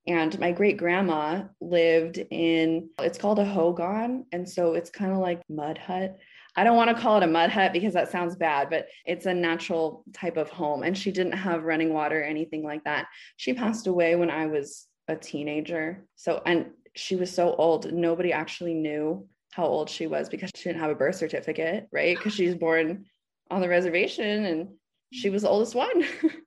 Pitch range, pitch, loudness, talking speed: 160-190 Hz, 175 Hz, -26 LUFS, 205 wpm